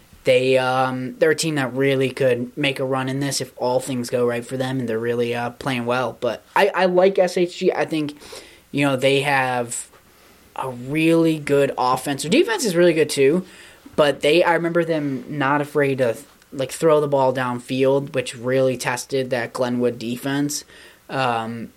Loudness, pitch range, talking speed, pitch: -20 LUFS, 125-150 Hz, 185 wpm, 135 Hz